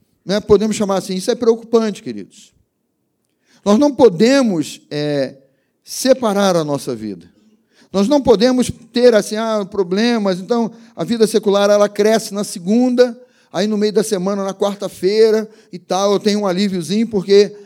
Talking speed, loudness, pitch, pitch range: 155 wpm, -16 LUFS, 210 Hz, 195-230 Hz